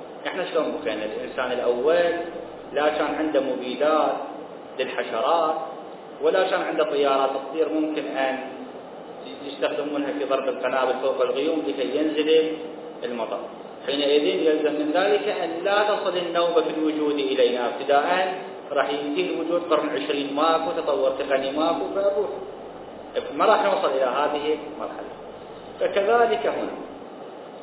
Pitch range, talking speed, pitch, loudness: 145-170 Hz, 120 wpm, 155 Hz, -24 LUFS